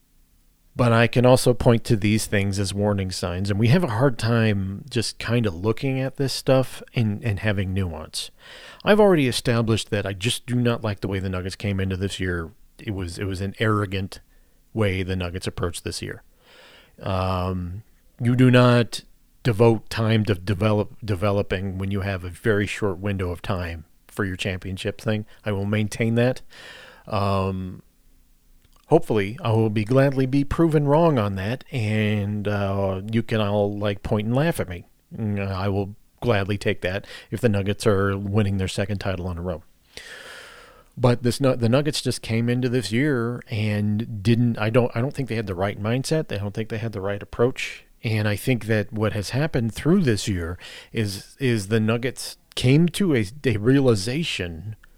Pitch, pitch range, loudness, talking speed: 110 Hz, 100-120 Hz, -23 LUFS, 185 wpm